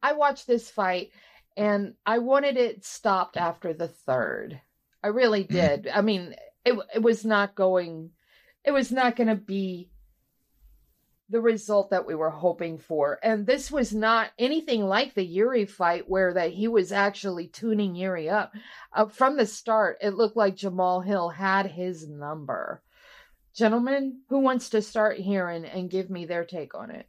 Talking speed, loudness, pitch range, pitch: 175 wpm, -26 LUFS, 180-230 Hz, 205 Hz